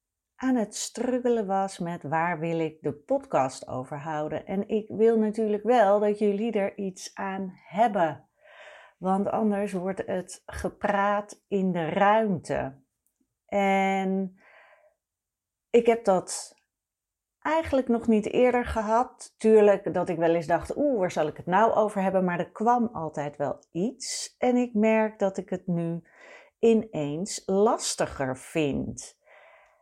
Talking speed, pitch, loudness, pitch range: 140 wpm, 200 Hz, -26 LUFS, 175-230 Hz